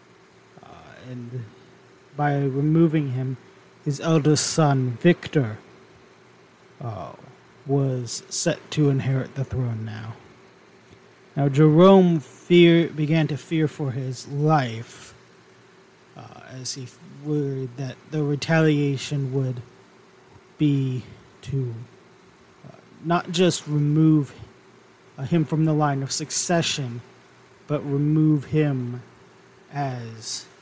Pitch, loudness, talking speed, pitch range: 140 Hz, -22 LUFS, 95 wpm, 125-155 Hz